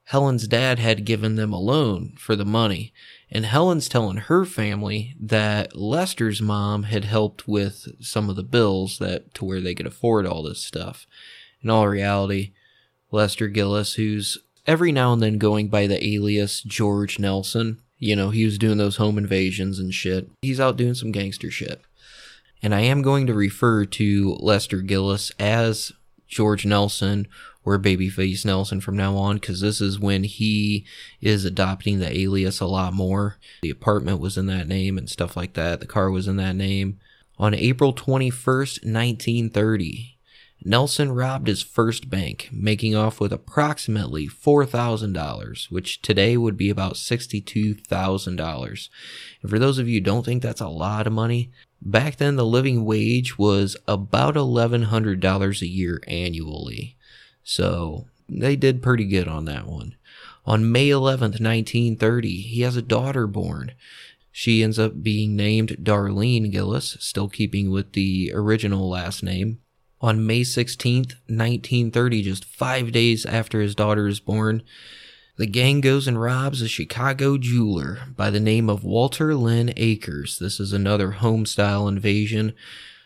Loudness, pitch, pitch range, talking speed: -22 LUFS, 105 Hz, 100-120 Hz, 160 wpm